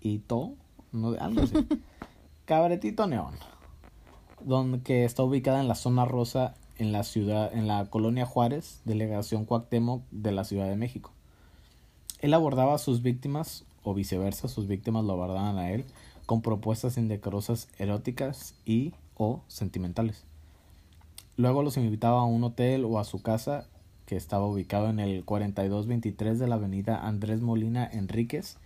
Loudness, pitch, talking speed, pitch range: -29 LUFS, 110 Hz, 145 wpm, 100-125 Hz